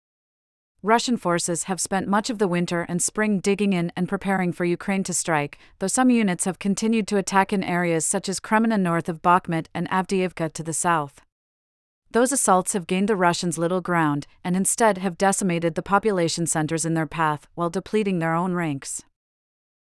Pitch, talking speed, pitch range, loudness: 180 Hz, 185 wpm, 165-195 Hz, -23 LUFS